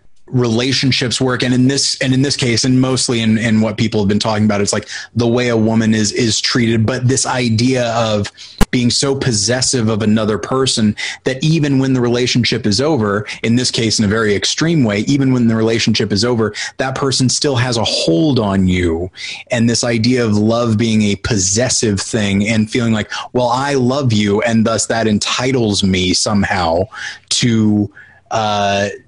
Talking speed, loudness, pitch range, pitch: 190 wpm, -14 LUFS, 105-125 Hz, 115 Hz